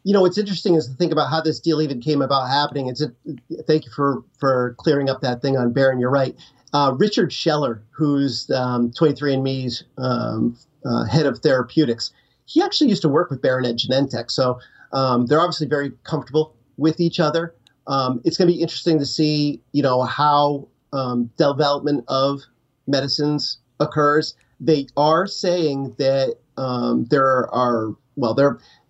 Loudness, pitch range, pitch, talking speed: -20 LUFS, 130-155 Hz, 140 Hz, 170 wpm